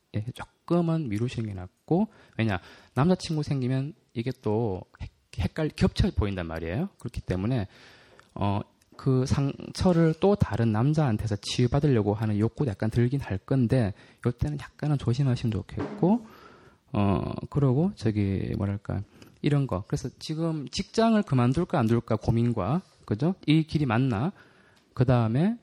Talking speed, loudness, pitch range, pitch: 295 characters per minute, -27 LUFS, 110-150 Hz, 125 Hz